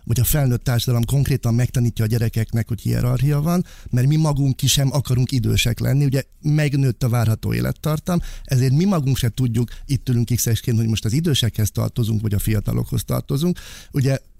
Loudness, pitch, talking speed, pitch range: -20 LUFS, 125 Hz, 175 wpm, 115-140 Hz